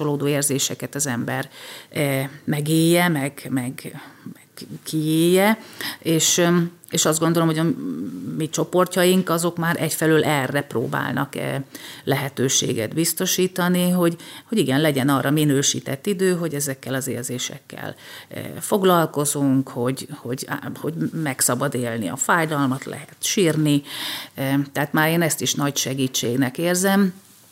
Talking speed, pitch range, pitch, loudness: 120 wpm, 135-175 Hz, 155 Hz, -21 LUFS